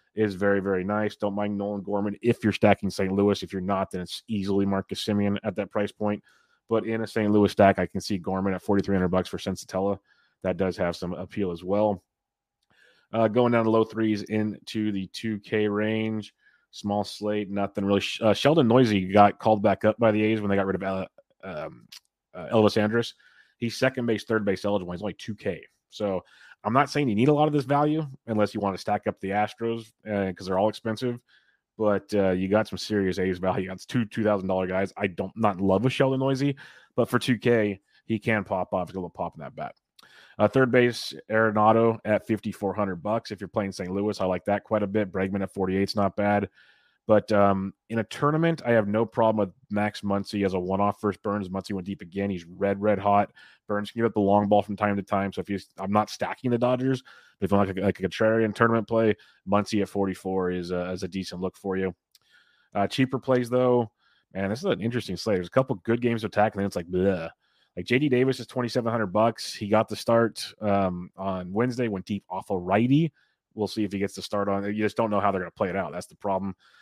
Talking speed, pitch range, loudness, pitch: 235 wpm, 95-110 Hz, -26 LUFS, 105 Hz